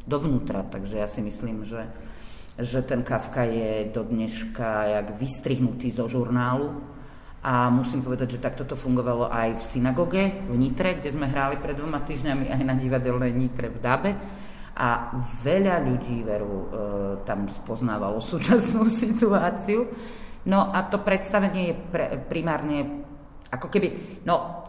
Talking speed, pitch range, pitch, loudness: 140 wpm, 120-170 Hz, 130 Hz, -26 LUFS